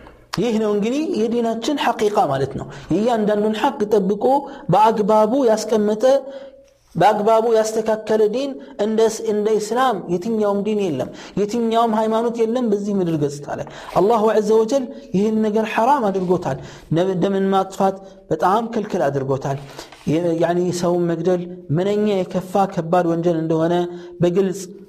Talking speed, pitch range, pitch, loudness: 135 wpm, 180-225 Hz, 210 Hz, -19 LUFS